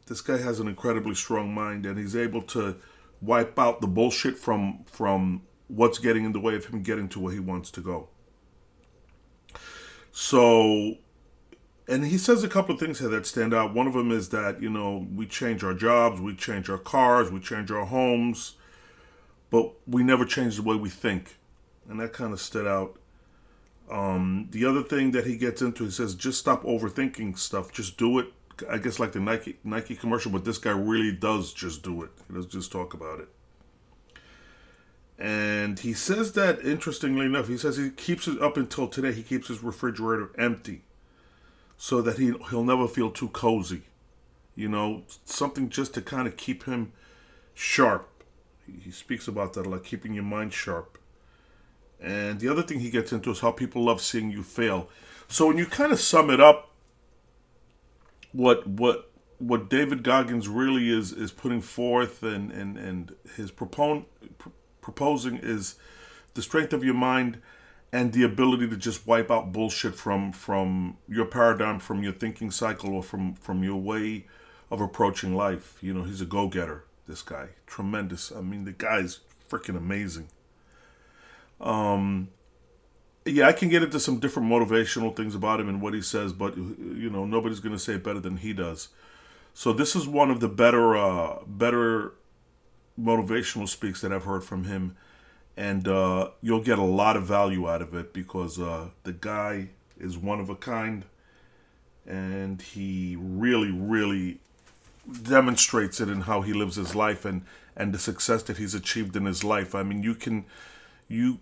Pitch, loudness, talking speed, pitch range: 110 Hz, -26 LUFS, 180 wpm, 95-120 Hz